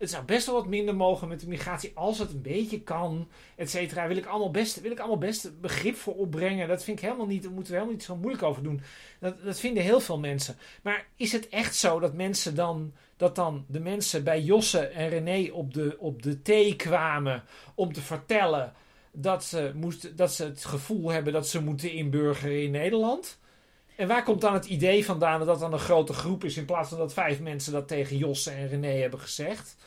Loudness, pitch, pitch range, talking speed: -29 LUFS, 175 Hz, 155-200 Hz, 225 wpm